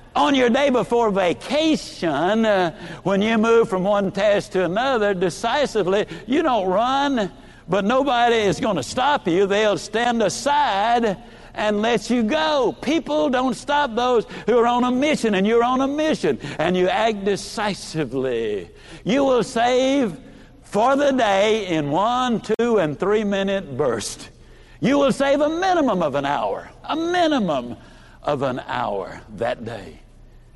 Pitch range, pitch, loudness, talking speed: 200-270 Hz, 230 Hz, -20 LUFS, 150 wpm